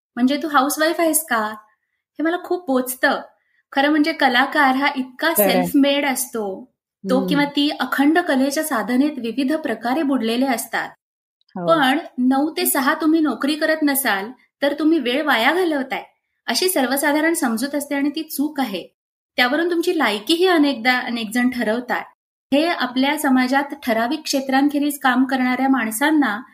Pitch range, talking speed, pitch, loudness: 255-305 Hz, 145 wpm, 280 Hz, -19 LUFS